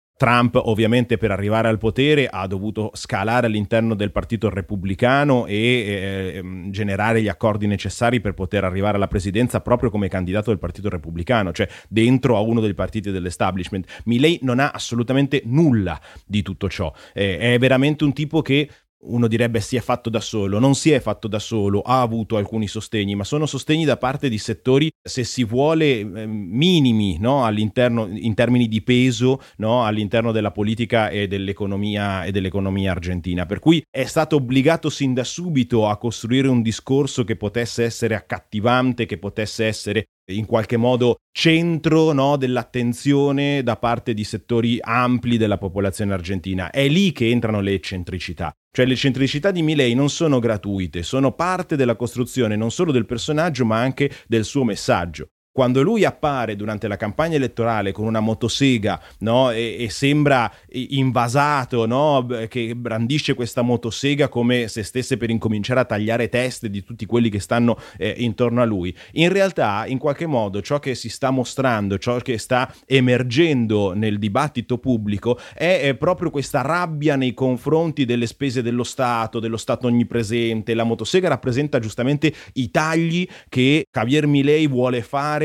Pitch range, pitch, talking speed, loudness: 105-135 Hz, 120 Hz, 165 wpm, -20 LUFS